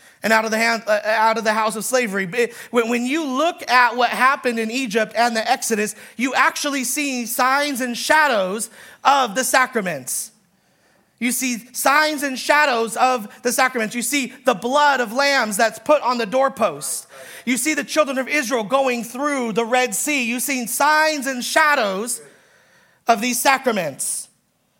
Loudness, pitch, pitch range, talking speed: -19 LUFS, 255 Hz, 230-280 Hz, 155 wpm